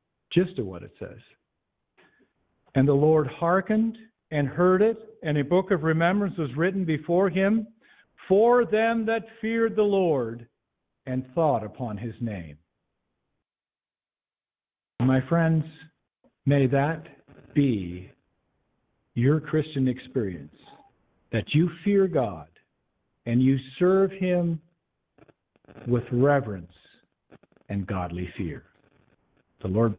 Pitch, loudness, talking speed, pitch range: 155 Hz, -25 LUFS, 110 wpm, 125-190 Hz